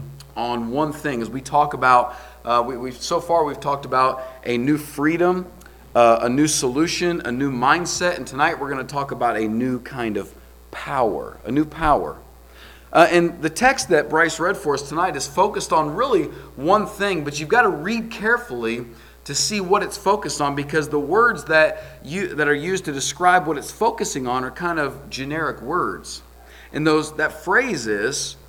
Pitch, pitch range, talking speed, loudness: 145 Hz, 125-170 Hz, 195 wpm, -20 LUFS